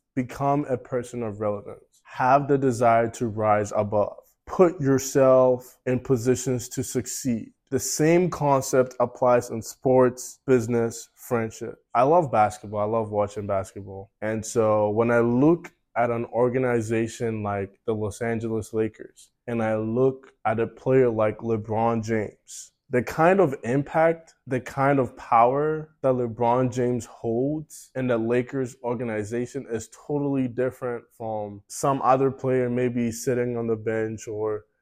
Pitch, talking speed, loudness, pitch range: 120 Hz, 145 wpm, -24 LUFS, 110-130 Hz